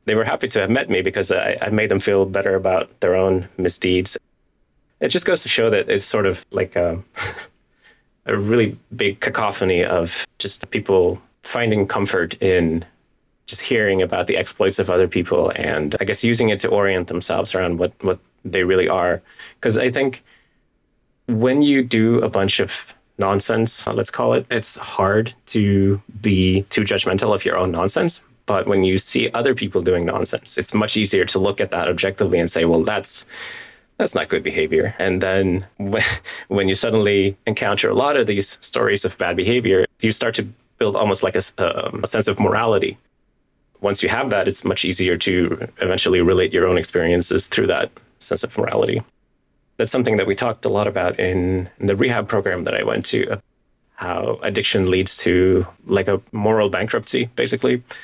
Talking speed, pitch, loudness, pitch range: 185 wpm, 95 Hz, -18 LUFS, 90-110 Hz